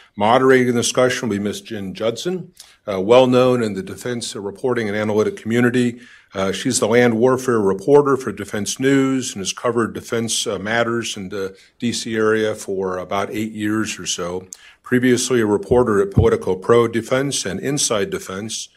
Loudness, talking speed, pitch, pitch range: -18 LUFS, 170 wpm, 115 Hz, 100-125 Hz